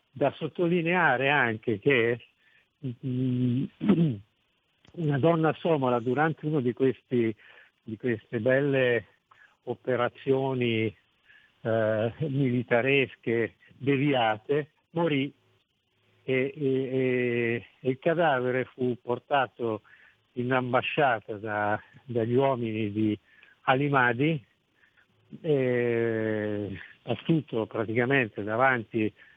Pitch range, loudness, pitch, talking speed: 115-140 Hz, -27 LUFS, 125 Hz, 75 wpm